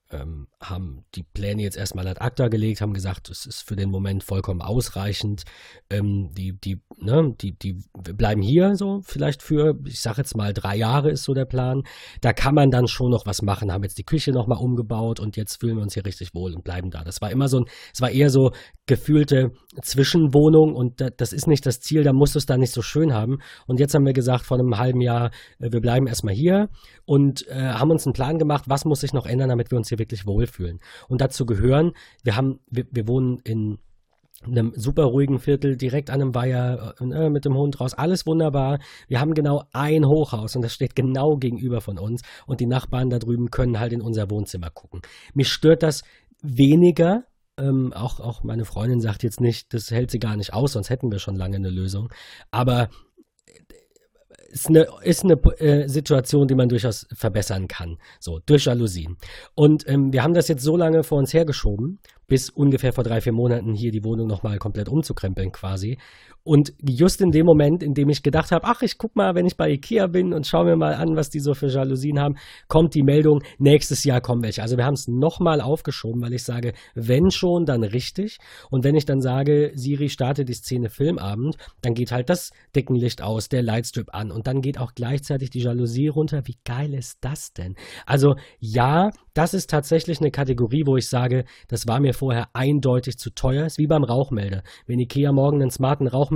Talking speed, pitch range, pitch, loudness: 210 wpm, 115-145 Hz, 130 Hz, -21 LUFS